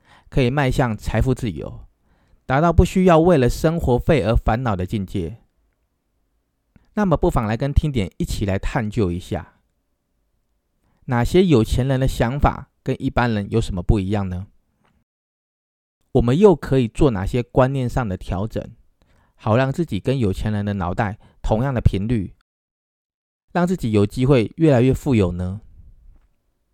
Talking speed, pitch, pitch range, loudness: 225 characters per minute, 110 Hz, 95-130 Hz, -20 LUFS